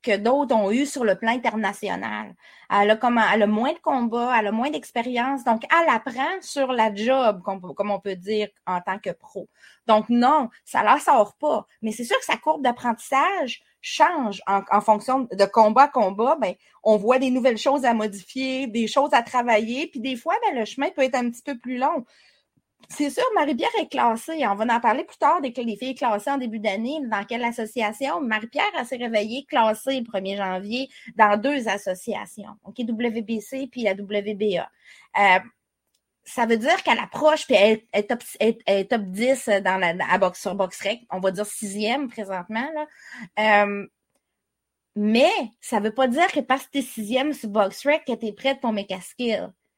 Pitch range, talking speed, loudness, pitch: 210-270 Hz, 200 wpm, -23 LUFS, 230 Hz